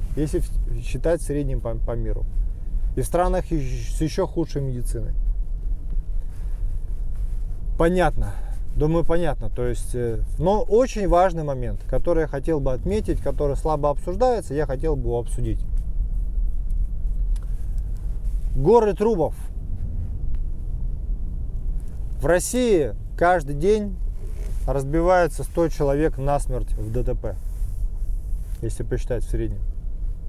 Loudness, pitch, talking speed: -25 LUFS, 115 Hz, 100 wpm